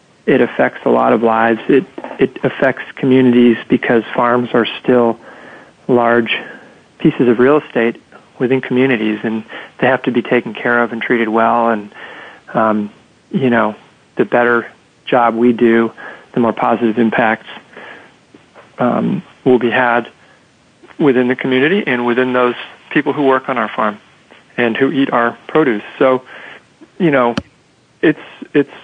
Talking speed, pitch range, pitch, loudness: 150 wpm, 115-130 Hz, 120 Hz, -14 LUFS